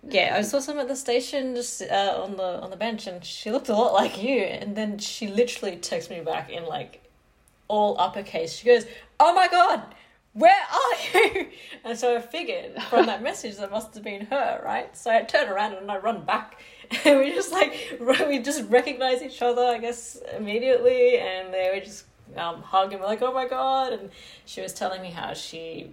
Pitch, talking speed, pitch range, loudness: 235 Hz, 215 wpm, 200-275 Hz, -24 LUFS